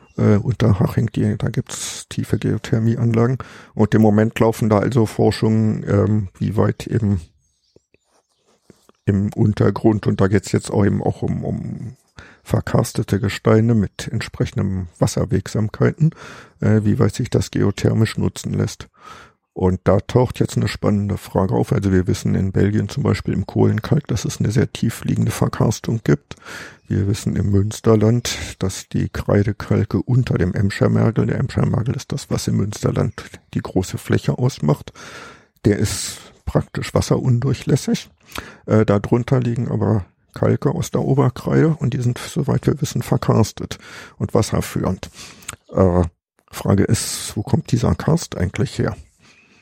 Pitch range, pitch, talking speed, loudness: 100-125 Hz, 110 Hz, 145 wpm, -19 LUFS